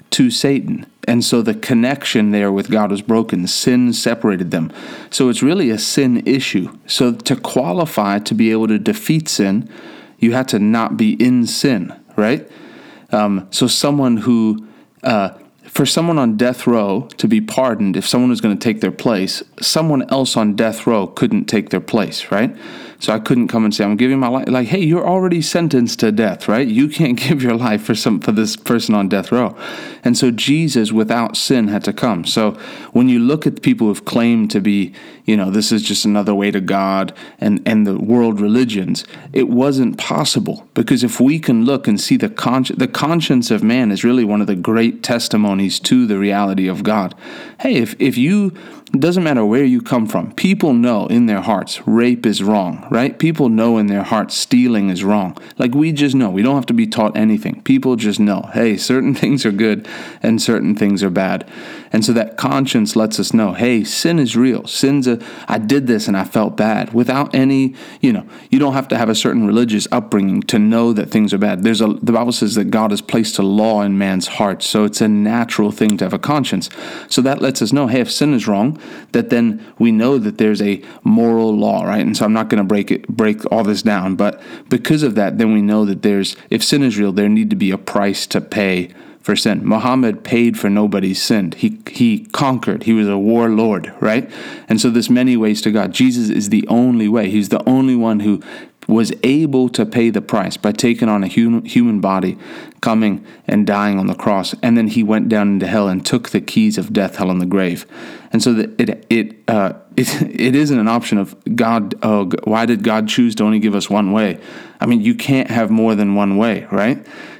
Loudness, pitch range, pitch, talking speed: -15 LUFS, 105-135 Hz, 115 Hz, 220 wpm